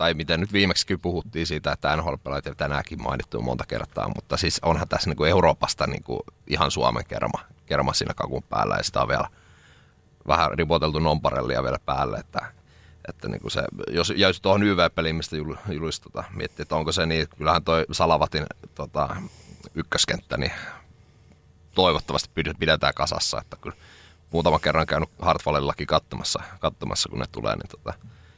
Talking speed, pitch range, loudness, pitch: 140 wpm, 75-90 Hz, -24 LUFS, 80 Hz